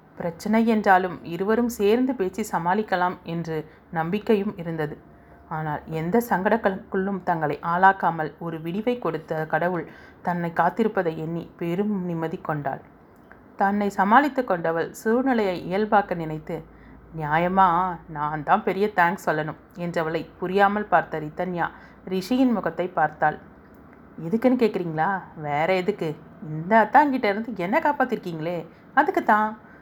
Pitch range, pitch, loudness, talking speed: 165-210 Hz, 180 Hz, -24 LUFS, 105 wpm